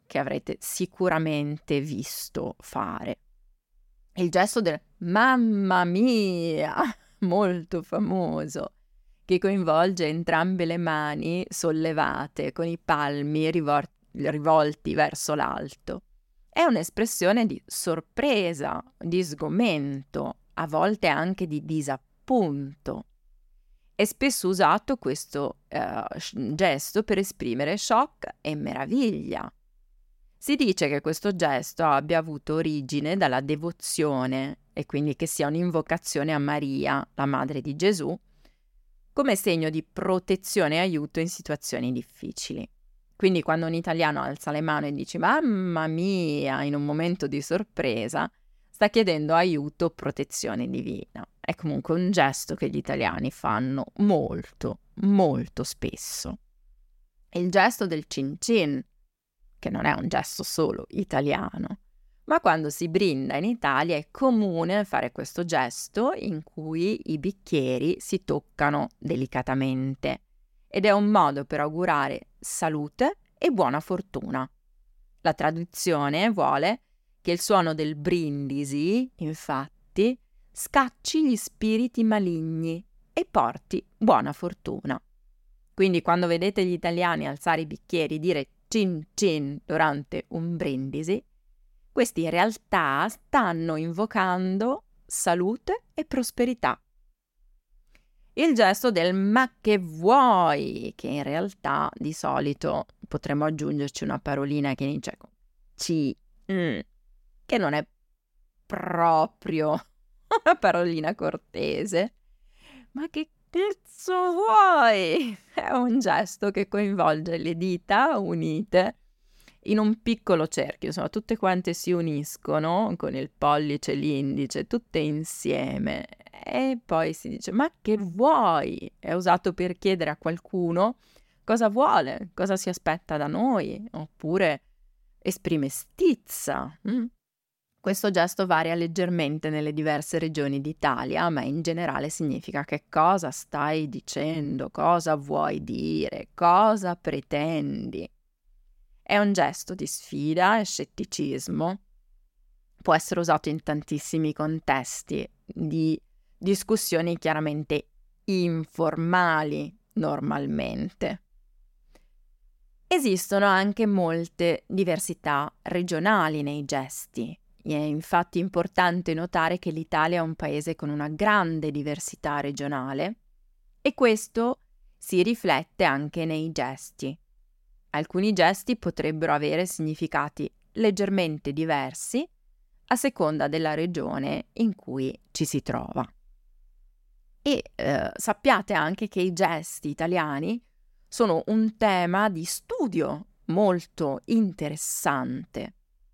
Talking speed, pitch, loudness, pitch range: 110 wpm, 170 Hz, -26 LUFS, 150-200 Hz